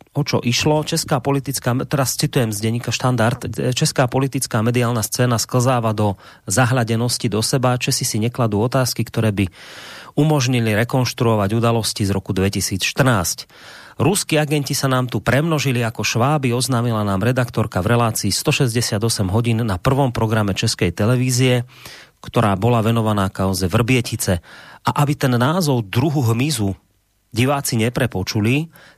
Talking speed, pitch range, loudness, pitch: 135 wpm, 110-135 Hz, -18 LUFS, 120 Hz